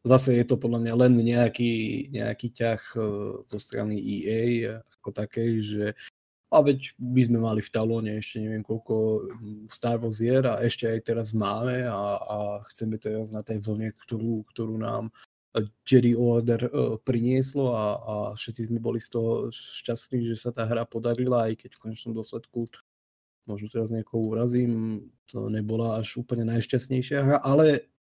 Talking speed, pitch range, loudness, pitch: 160 wpm, 110-120 Hz, -27 LUFS, 115 Hz